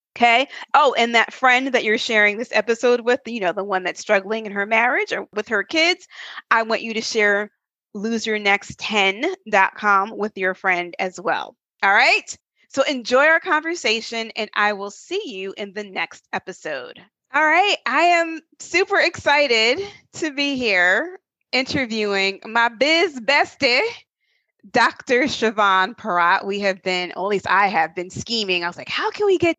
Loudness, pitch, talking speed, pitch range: -19 LUFS, 225 Hz, 170 wpm, 200-285 Hz